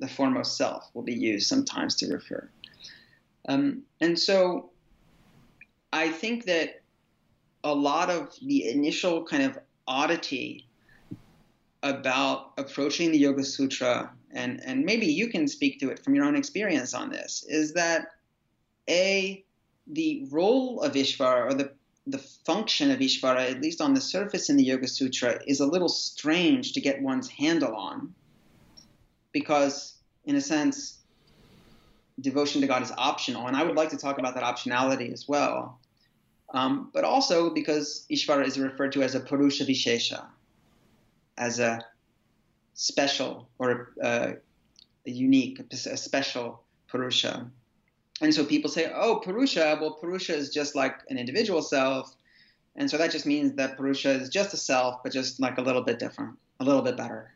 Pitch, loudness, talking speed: 155 Hz, -27 LUFS, 160 wpm